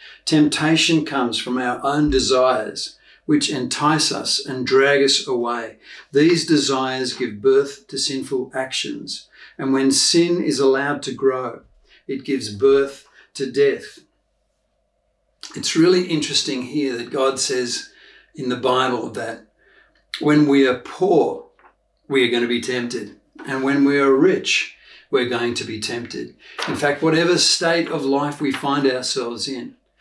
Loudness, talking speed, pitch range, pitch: -19 LUFS, 145 wpm, 130-155 Hz, 140 Hz